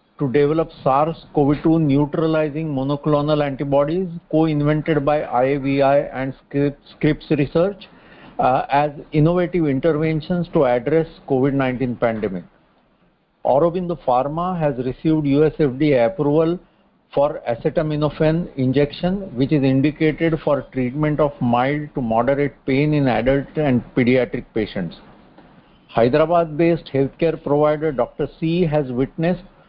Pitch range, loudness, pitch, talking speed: 135-160 Hz, -19 LUFS, 150 Hz, 105 wpm